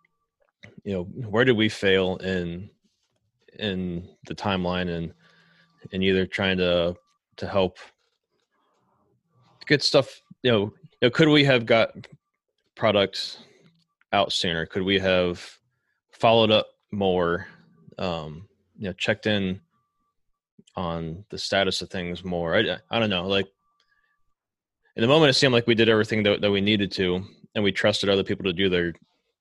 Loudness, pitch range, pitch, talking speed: -23 LUFS, 95-120 Hz, 100 Hz, 150 wpm